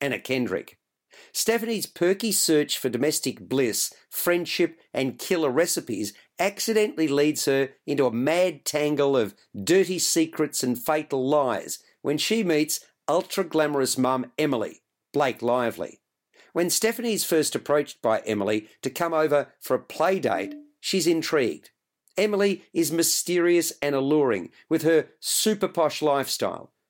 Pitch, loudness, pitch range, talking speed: 155 Hz, -24 LUFS, 140-180 Hz, 130 wpm